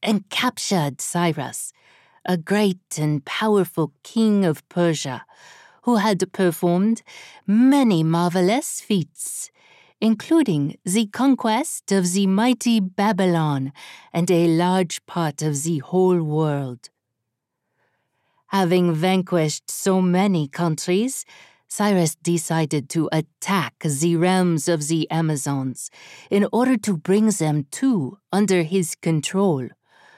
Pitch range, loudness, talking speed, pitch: 160-205 Hz, -21 LUFS, 105 wpm, 180 Hz